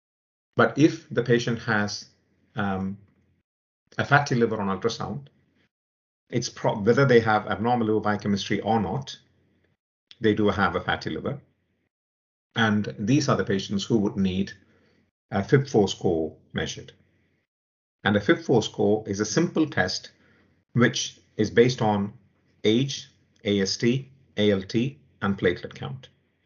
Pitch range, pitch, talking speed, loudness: 95-120 Hz, 105 Hz, 130 wpm, -25 LUFS